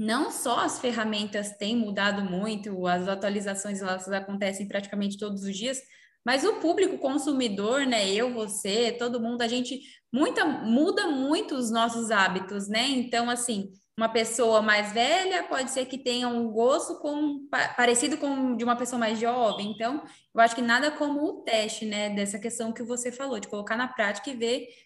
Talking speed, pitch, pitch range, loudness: 175 wpm, 235 Hz, 210-265 Hz, -27 LUFS